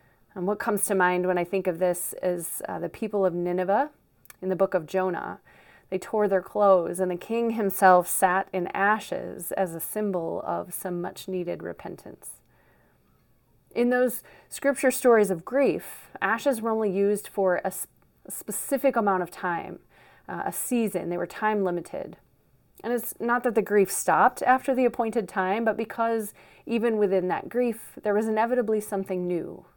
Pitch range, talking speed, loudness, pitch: 185-230 Hz, 175 wpm, -26 LUFS, 200 Hz